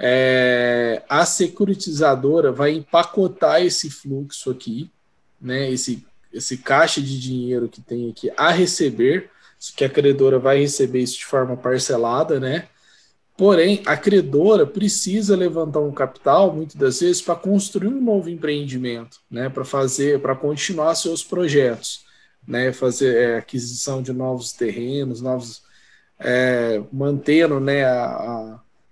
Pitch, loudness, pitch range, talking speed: 135 Hz, -19 LUFS, 125-170 Hz, 135 wpm